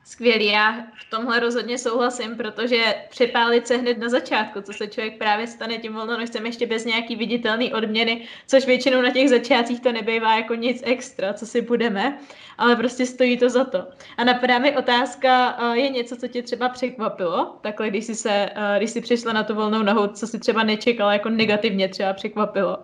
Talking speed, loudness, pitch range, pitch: 190 wpm, -21 LUFS, 220-250 Hz, 235 Hz